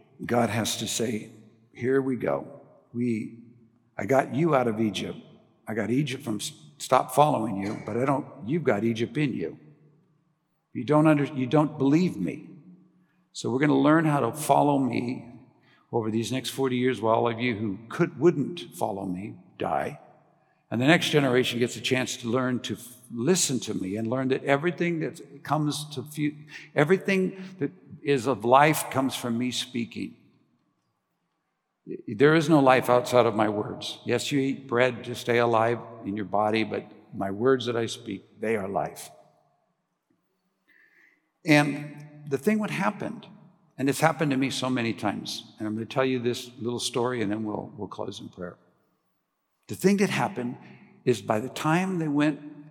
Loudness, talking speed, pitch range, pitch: -26 LUFS, 180 wpm, 115-150 Hz, 130 Hz